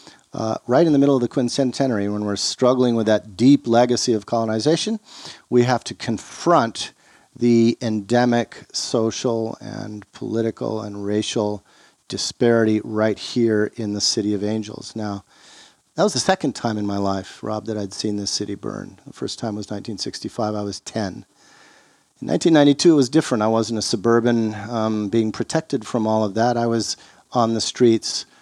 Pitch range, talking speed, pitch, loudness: 105-120 Hz, 170 wpm, 115 Hz, -20 LUFS